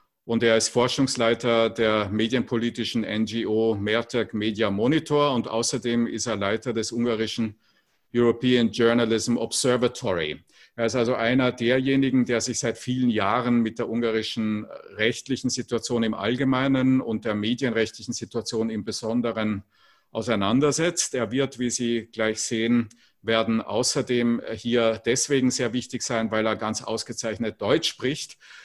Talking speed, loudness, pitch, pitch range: 130 wpm, -24 LUFS, 115 Hz, 110-125 Hz